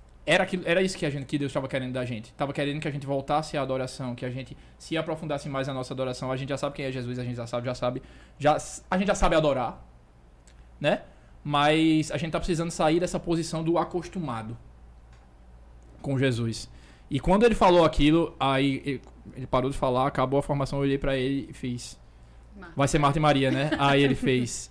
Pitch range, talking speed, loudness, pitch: 125-155 Hz, 220 wpm, -26 LUFS, 140 Hz